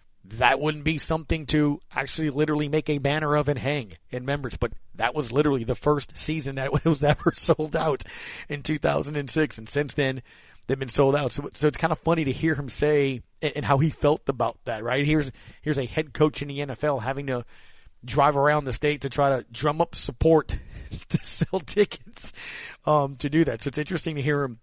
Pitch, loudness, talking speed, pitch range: 145 Hz, -25 LUFS, 210 wpm, 135-155 Hz